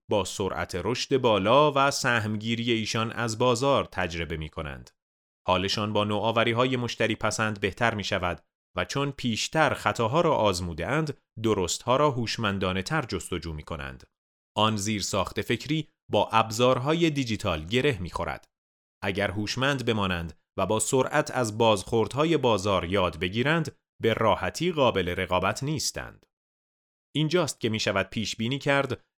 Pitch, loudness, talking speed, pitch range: 110 Hz, -26 LUFS, 140 wpm, 95-125 Hz